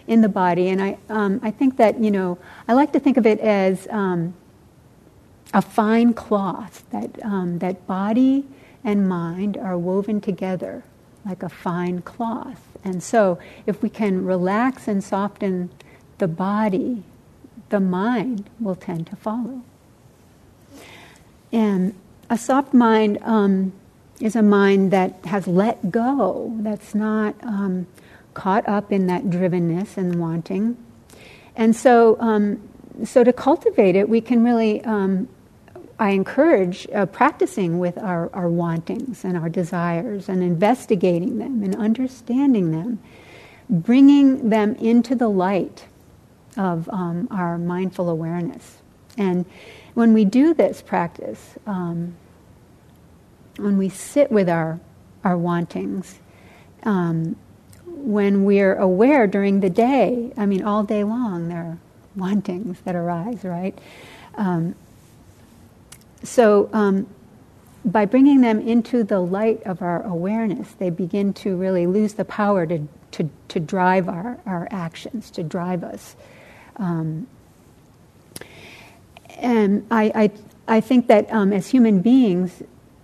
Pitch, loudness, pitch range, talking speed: 200 Hz, -20 LUFS, 185-225 Hz, 130 wpm